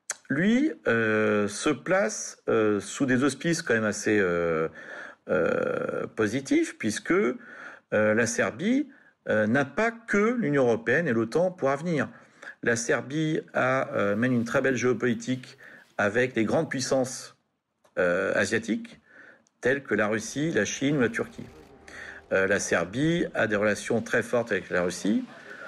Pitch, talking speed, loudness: 140 Hz, 145 wpm, -26 LUFS